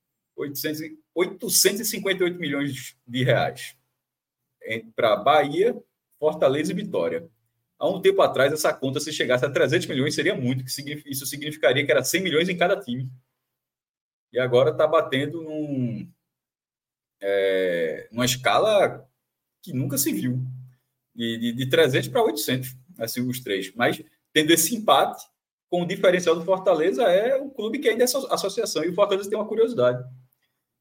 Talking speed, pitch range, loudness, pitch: 150 wpm, 125-180 Hz, -23 LUFS, 145 Hz